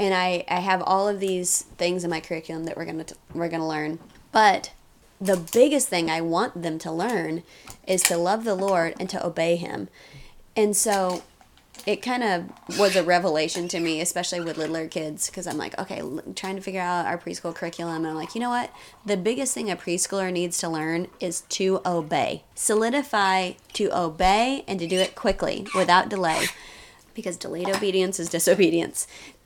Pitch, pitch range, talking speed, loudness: 180 Hz, 170-195 Hz, 190 wpm, -24 LUFS